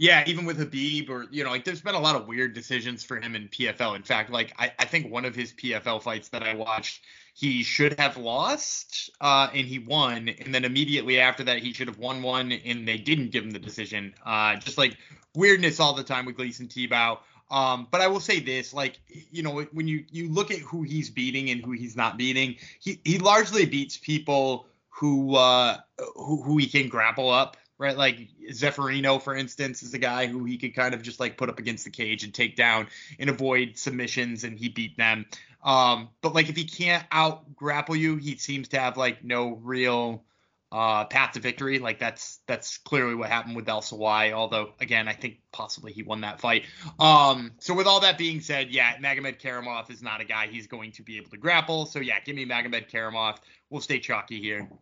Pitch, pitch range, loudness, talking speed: 130 Hz, 115-145 Hz, -25 LUFS, 220 wpm